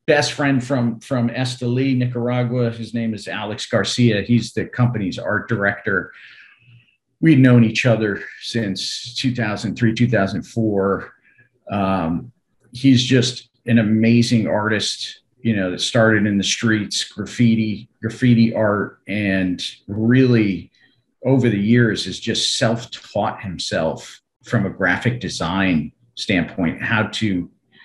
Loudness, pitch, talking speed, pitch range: -19 LUFS, 115 Hz, 120 wpm, 105-120 Hz